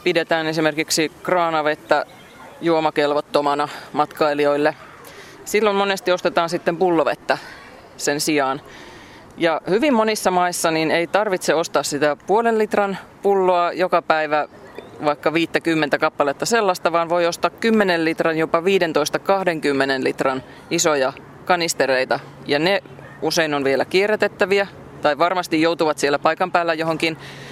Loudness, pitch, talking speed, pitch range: -19 LUFS, 165 Hz, 115 wpm, 150-180 Hz